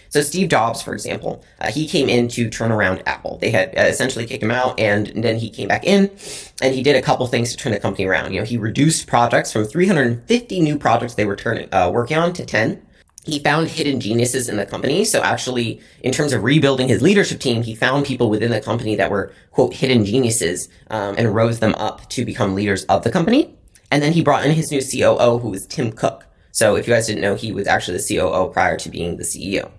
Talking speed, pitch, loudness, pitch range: 245 wpm, 120 Hz, -18 LUFS, 105-140 Hz